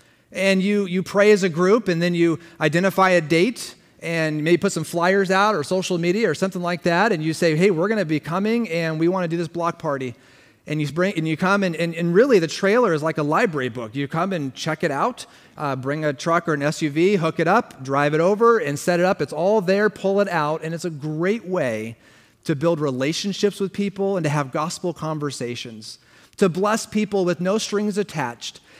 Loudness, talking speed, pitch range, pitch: -21 LUFS, 230 wpm, 155-195 Hz, 170 Hz